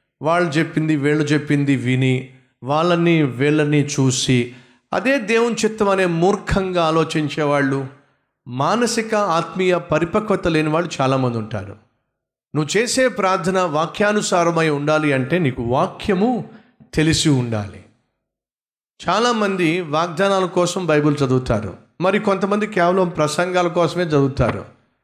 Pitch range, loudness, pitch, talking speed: 135-185 Hz, -18 LUFS, 160 Hz, 100 wpm